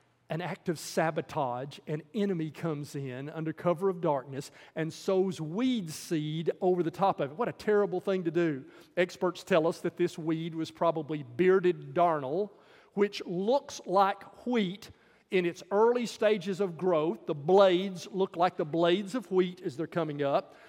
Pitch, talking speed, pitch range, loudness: 175 Hz, 170 wpm, 160-195 Hz, -30 LUFS